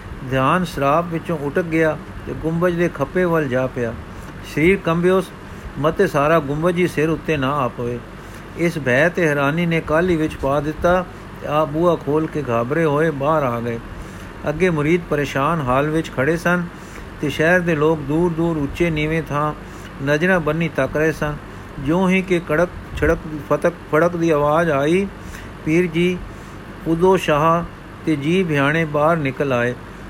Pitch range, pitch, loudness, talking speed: 140-170 Hz, 155 Hz, -19 LUFS, 160 wpm